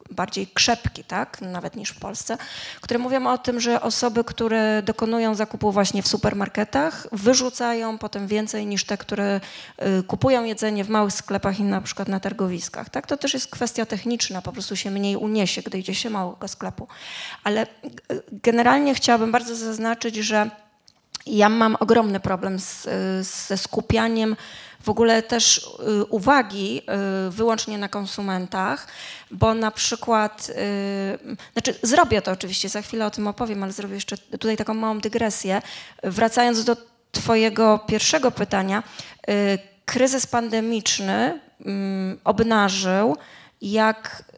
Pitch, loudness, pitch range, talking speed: 215 Hz, -22 LUFS, 200-230 Hz, 135 wpm